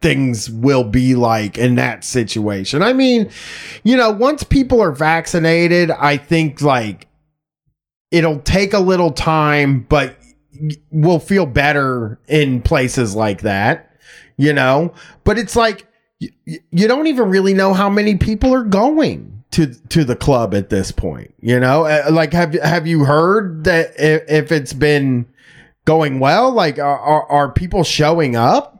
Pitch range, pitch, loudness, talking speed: 130-180 Hz, 155 Hz, -15 LUFS, 150 wpm